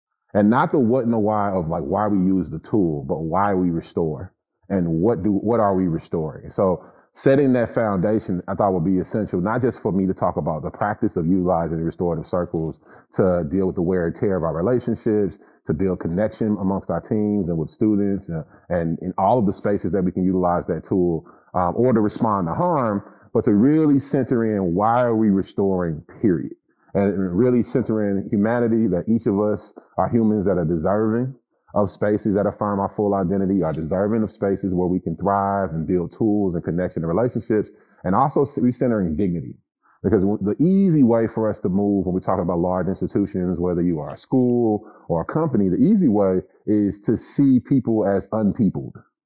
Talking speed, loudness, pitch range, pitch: 200 wpm, -21 LUFS, 90-110 Hz, 100 Hz